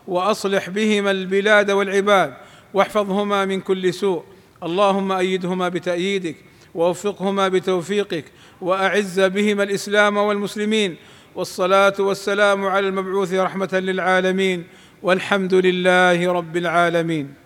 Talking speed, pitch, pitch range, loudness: 95 wpm, 190 Hz, 180-200 Hz, -19 LUFS